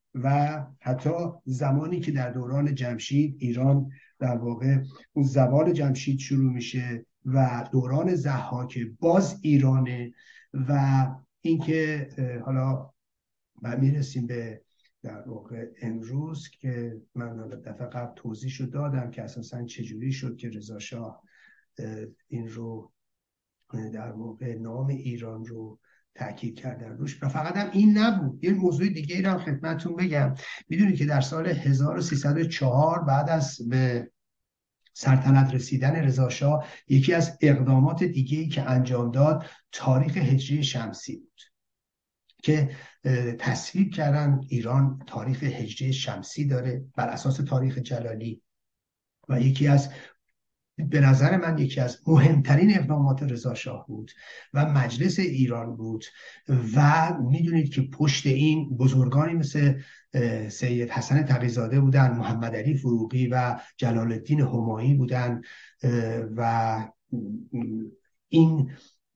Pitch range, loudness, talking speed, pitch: 120-145 Hz, -25 LUFS, 115 wpm, 135 Hz